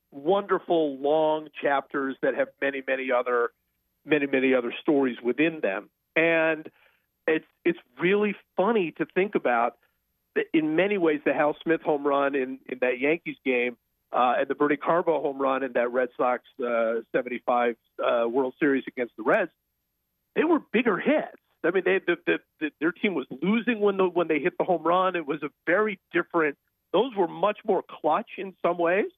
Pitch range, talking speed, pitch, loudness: 130-185 Hz, 185 wpm, 155 Hz, -26 LUFS